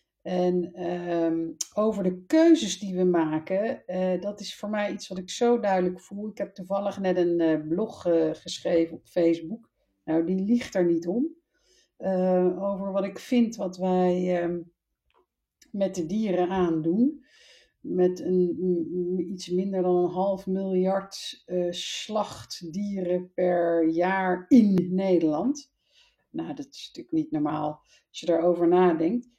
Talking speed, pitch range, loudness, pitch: 150 wpm, 175-200 Hz, -26 LUFS, 180 Hz